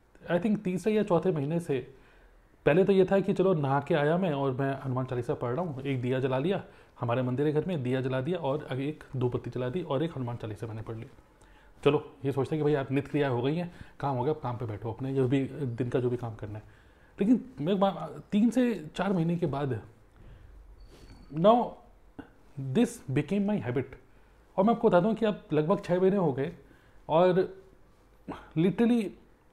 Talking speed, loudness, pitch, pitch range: 215 wpm, -29 LUFS, 145 Hz, 125-185 Hz